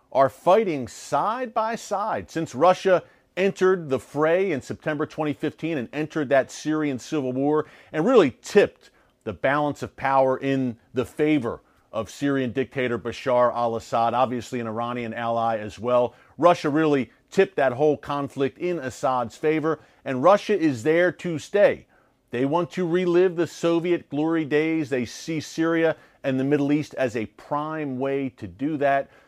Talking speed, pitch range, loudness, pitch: 160 wpm, 130-160 Hz, -24 LUFS, 145 Hz